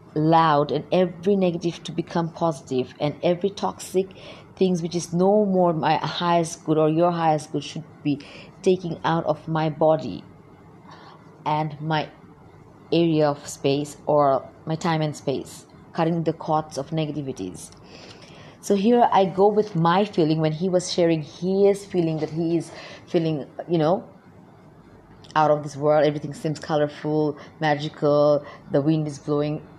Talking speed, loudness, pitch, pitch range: 150 wpm, -23 LUFS, 160 Hz, 150-175 Hz